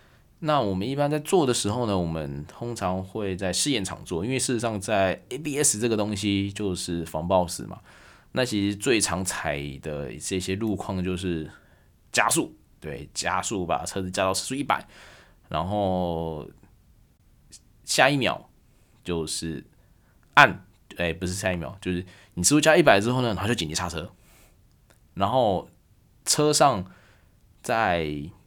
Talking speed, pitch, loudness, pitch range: 220 characters per minute, 95 Hz, -25 LUFS, 85-110 Hz